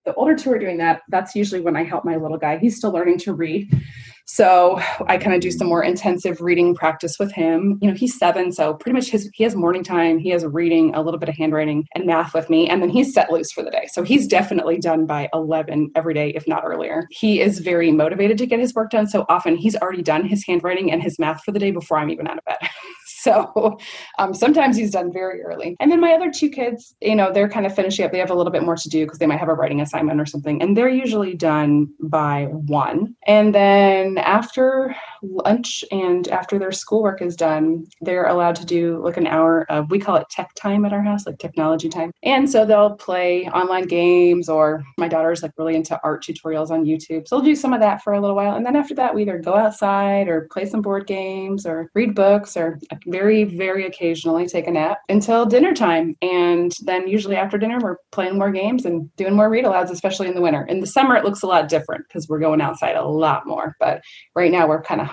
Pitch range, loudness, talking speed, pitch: 165-205 Hz, -19 LUFS, 245 wpm, 180 Hz